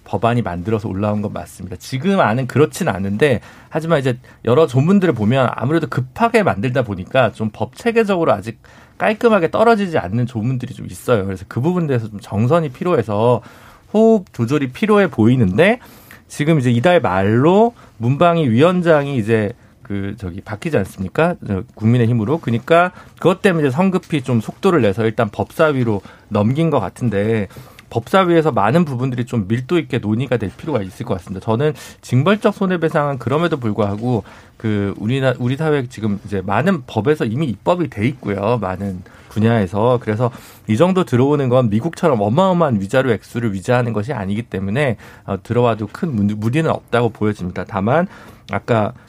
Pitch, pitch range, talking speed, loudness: 120 Hz, 105-155 Hz, 380 characters per minute, -17 LUFS